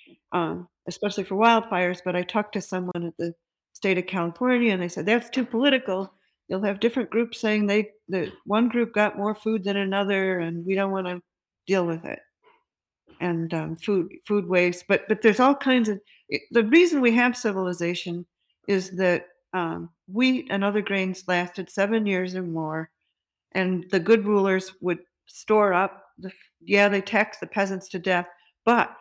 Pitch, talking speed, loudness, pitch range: 195 Hz, 180 wpm, -24 LUFS, 180-220 Hz